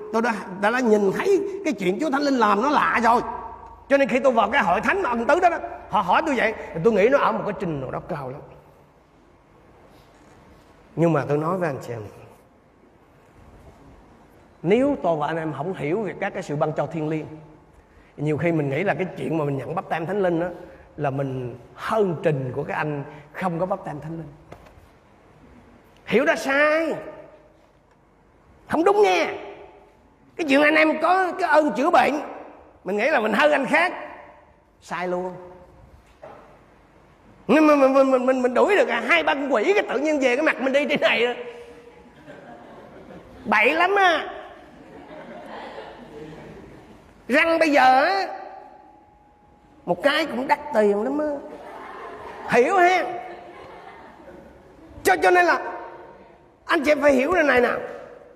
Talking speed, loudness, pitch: 175 wpm, -21 LUFS, 225 Hz